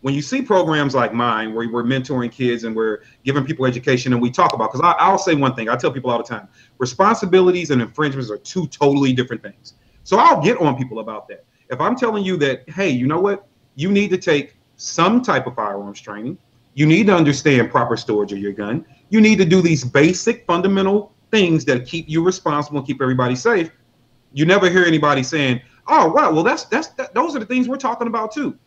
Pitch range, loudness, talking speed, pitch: 125-185 Hz, -17 LUFS, 225 wpm, 145 Hz